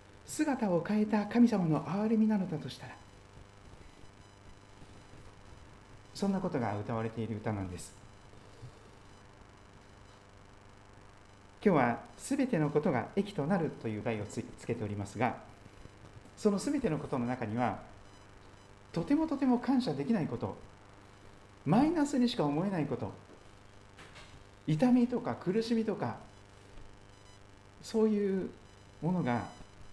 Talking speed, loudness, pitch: 235 characters per minute, -33 LUFS, 100 Hz